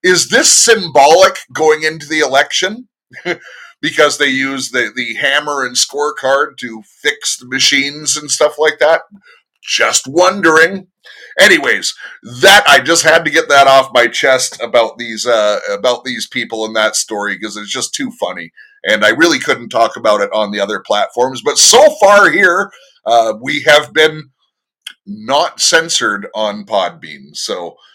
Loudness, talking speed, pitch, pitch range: -11 LUFS, 160 wpm, 150 Hz, 125-185 Hz